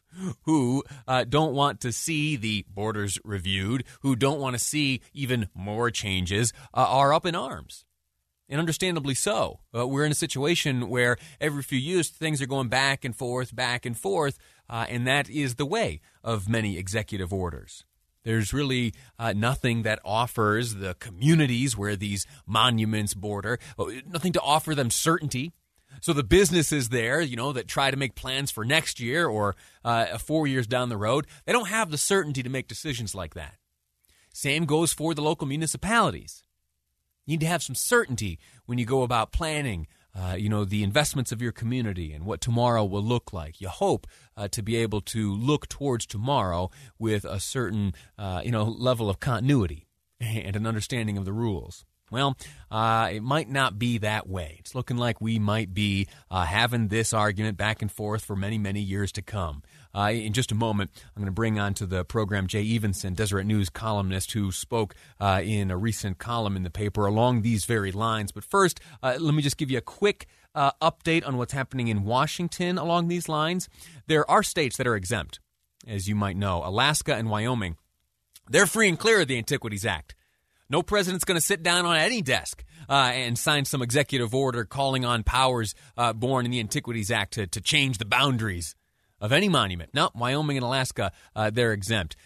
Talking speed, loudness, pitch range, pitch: 195 wpm, -26 LUFS, 100-140 Hz, 120 Hz